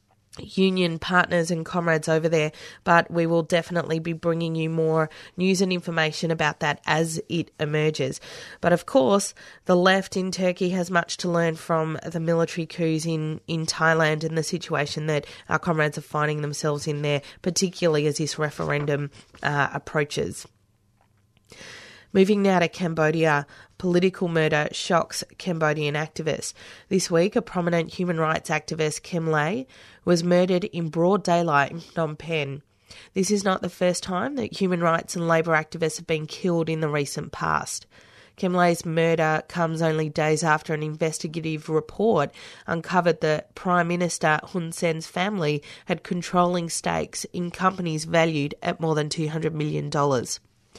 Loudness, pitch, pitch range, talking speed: -24 LUFS, 165 Hz, 155-175 Hz, 155 wpm